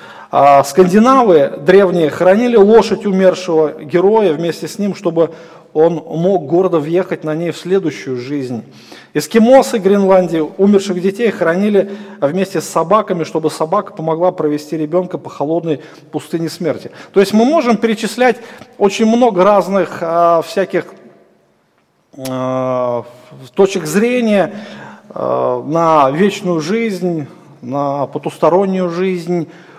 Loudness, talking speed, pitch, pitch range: -13 LUFS, 105 wpm, 175 Hz, 155-195 Hz